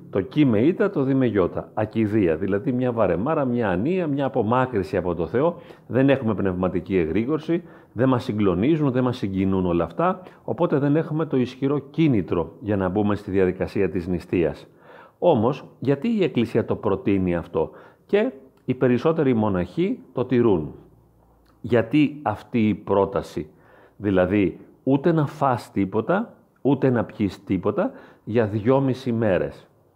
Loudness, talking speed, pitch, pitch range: -23 LUFS, 145 wpm, 120 Hz, 100-140 Hz